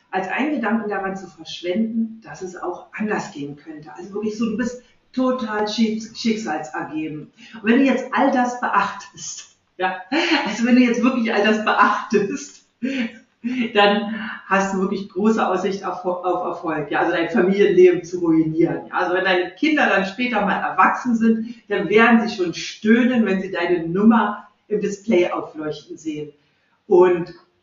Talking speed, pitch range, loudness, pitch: 155 wpm, 180-230 Hz, -20 LUFS, 205 Hz